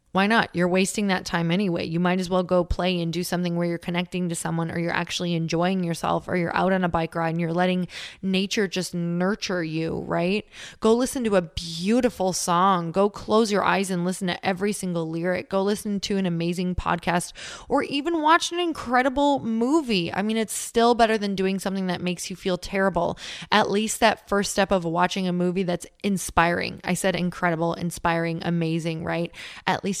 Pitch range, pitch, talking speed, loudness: 175-200 Hz, 185 Hz, 200 wpm, -24 LUFS